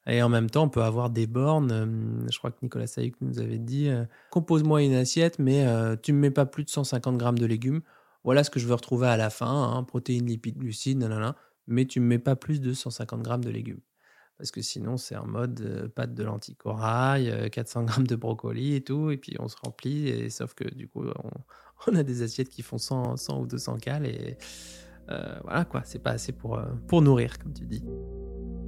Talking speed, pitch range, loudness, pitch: 240 wpm, 115-135 Hz, -28 LUFS, 125 Hz